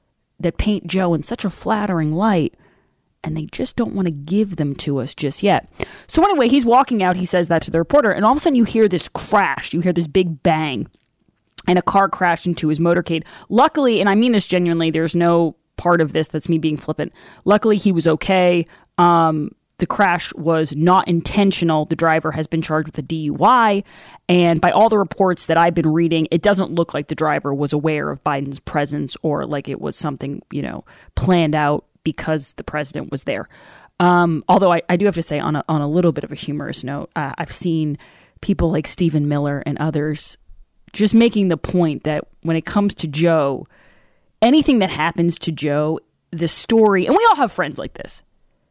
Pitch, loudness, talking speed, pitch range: 170 Hz, -18 LUFS, 210 wpm, 155-190 Hz